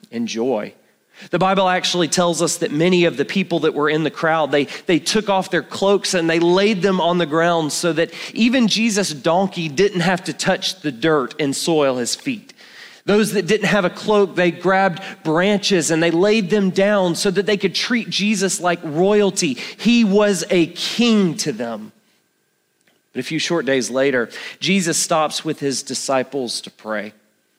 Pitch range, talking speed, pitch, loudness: 155-200 Hz, 185 wpm, 175 Hz, -18 LUFS